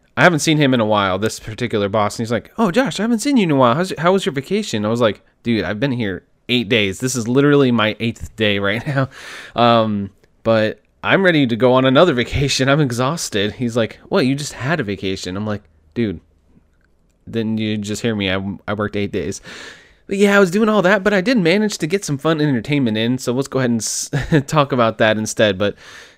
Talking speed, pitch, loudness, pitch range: 240 wpm, 120 Hz, -17 LUFS, 105-145 Hz